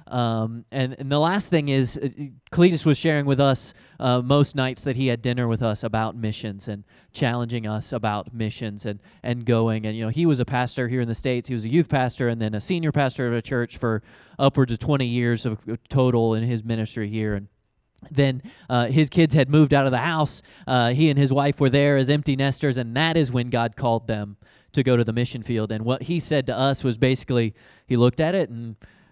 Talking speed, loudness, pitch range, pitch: 235 wpm, -23 LUFS, 115-140 Hz, 125 Hz